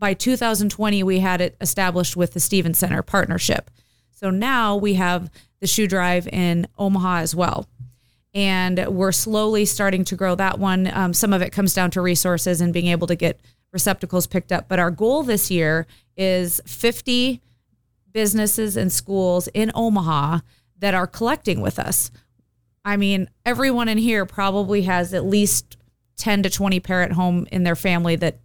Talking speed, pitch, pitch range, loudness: 170 wpm, 185 Hz, 170-200 Hz, -20 LUFS